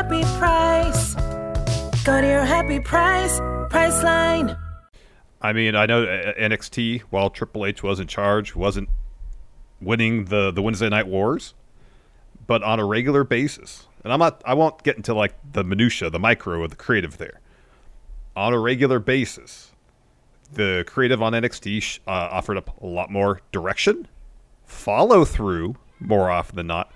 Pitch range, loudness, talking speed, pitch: 100-130 Hz, -21 LUFS, 145 wpm, 110 Hz